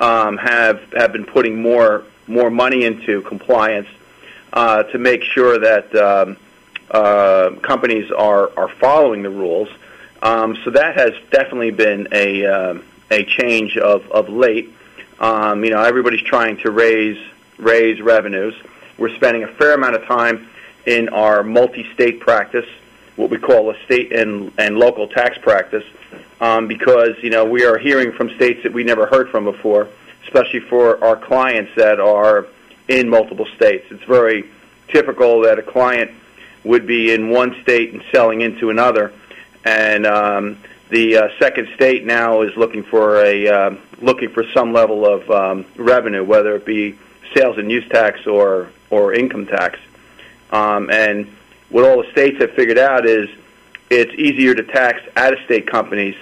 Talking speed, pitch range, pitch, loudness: 160 wpm, 105-120 Hz, 115 Hz, -14 LUFS